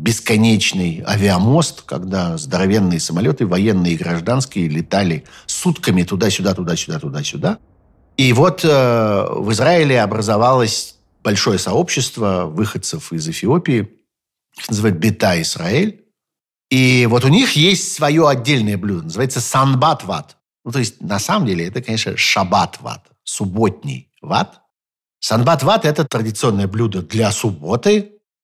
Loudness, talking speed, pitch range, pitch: -16 LUFS, 115 wpm, 100-150 Hz, 115 Hz